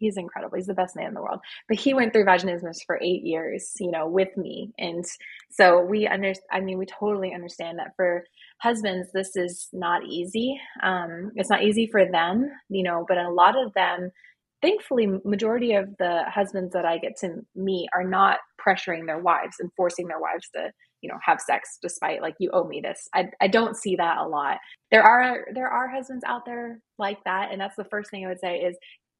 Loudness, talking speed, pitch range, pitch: -24 LUFS, 215 wpm, 180-215 Hz, 190 Hz